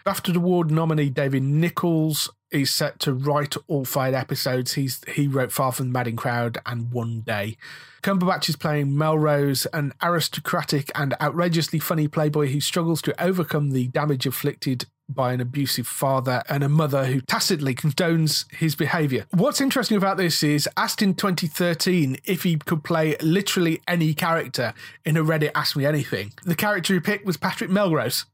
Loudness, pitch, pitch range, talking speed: -23 LUFS, 150 Hz, 135-175 Hz, 170 wpm